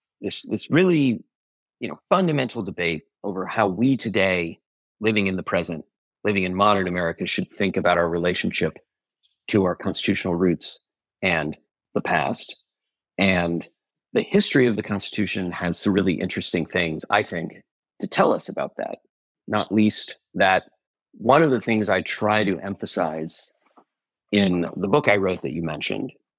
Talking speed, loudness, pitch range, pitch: 155 wpm, -23 LUFS, 90-105 Hz, 95 Hz